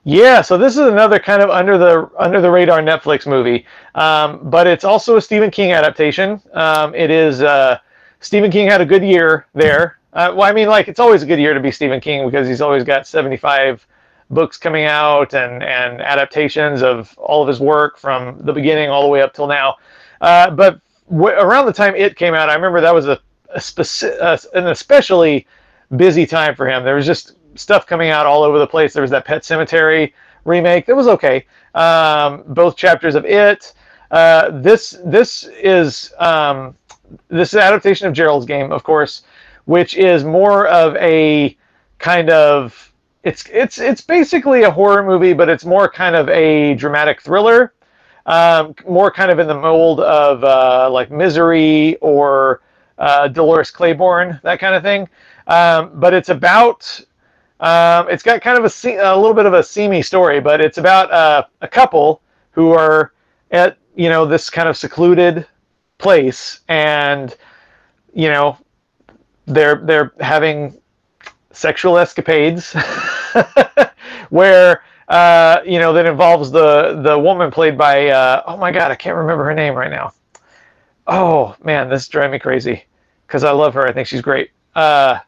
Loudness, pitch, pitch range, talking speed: -12 LUFS, 160 Hz, 150-180 Hz, 180 wpm